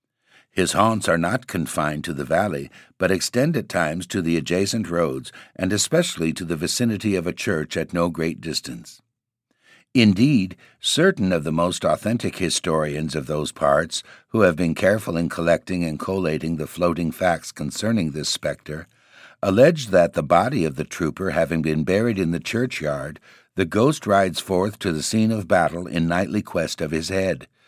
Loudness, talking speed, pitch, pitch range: -22 LUFS, 175 wpm, 90 Hz, 80-105 Hz